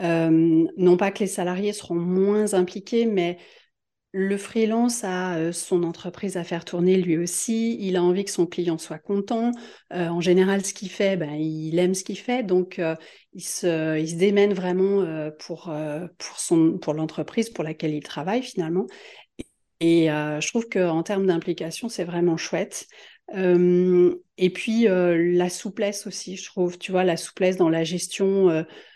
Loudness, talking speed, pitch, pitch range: -23 LUFS, 185 wpm, 180 Hz, 170-195 Hz